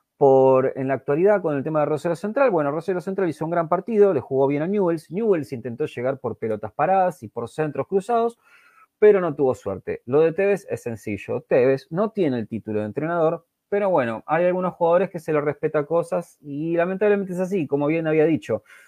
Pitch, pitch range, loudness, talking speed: 165 Hz, 140-195 Hz, -22 LUFS, 210 wpm